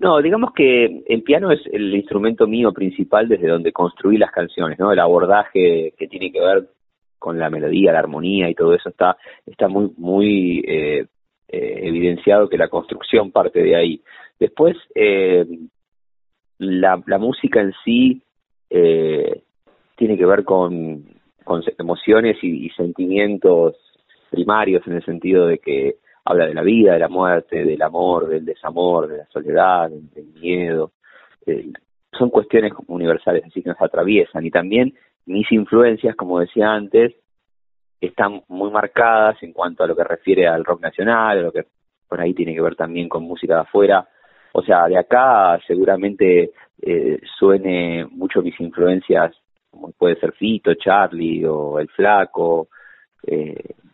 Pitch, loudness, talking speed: 105 Hz, -17 LUFS, 160 wpm